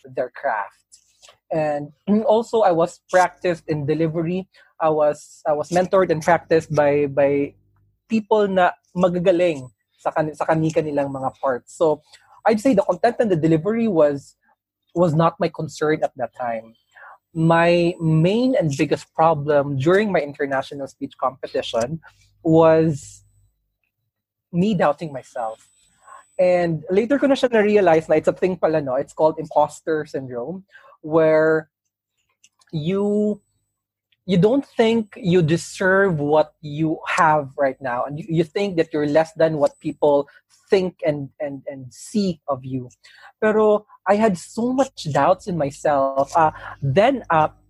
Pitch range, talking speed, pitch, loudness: 145-185 Hz, 140 wpm, 160 Hz, -20 LUFS